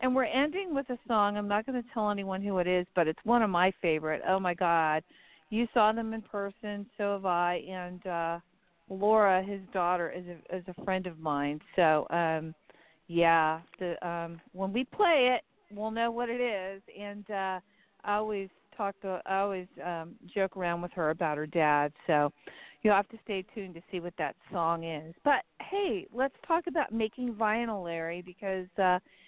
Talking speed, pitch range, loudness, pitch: 195 wpm, 170-215 Hz, -31 LUFS, 190 Hz